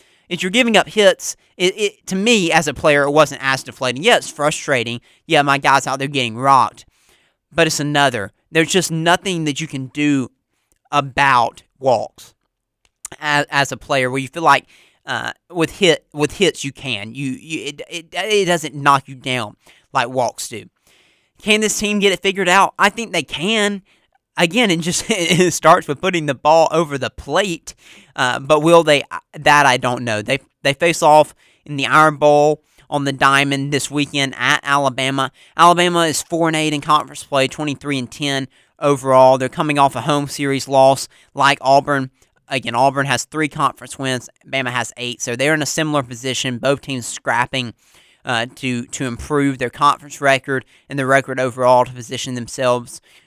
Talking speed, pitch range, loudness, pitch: 185 wpm, 130-160 Hz, -17 LUFS, 140 Hz